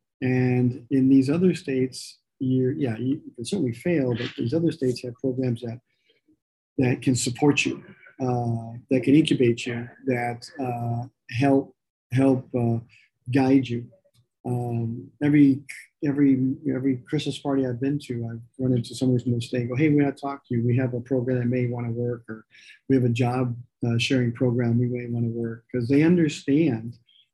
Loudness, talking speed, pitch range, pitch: -24 LUFS, 185 wpm, 120-135 Hz, 125 Hz